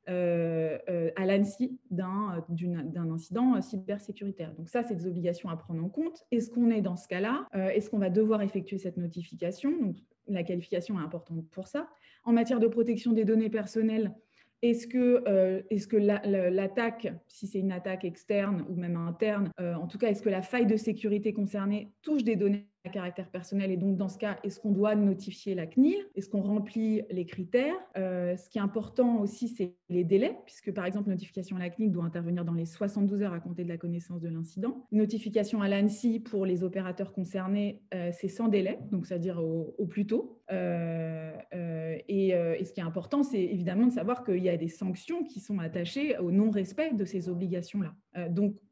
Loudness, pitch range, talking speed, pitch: -31 LUFS, 180-220 Hz, 200 wpm, 195 Hz